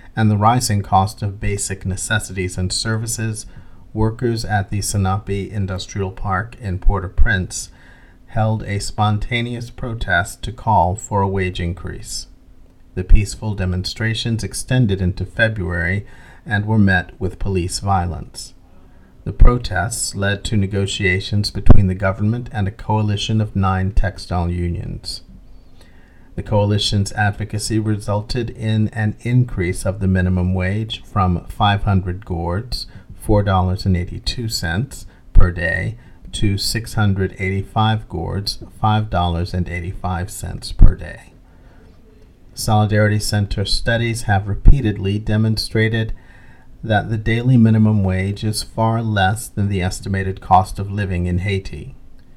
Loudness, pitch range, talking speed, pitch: -19 LUFS, 90-110 Hz, 115 wpm, 100 Hz